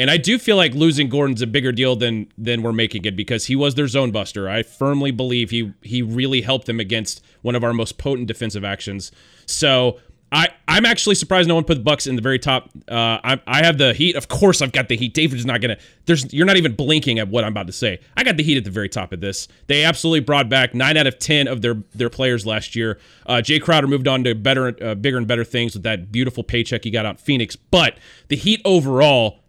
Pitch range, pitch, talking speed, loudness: 115-145 Hz, 125 Hz, 255 wpm, -18 LUFS